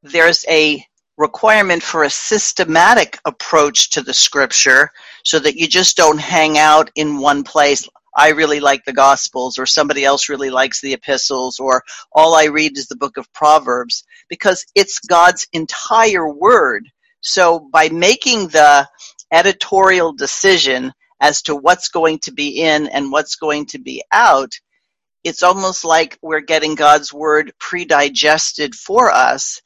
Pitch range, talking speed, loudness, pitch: 140-170 Hz, 155 wpm, -13 LUFS, 155 Hz